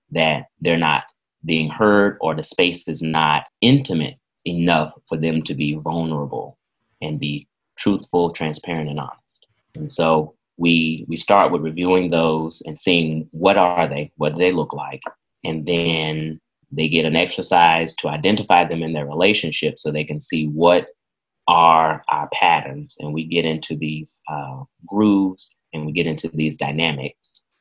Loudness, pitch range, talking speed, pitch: -19 LUFS, 75-85 Hz, 160 wpm, 80 Hz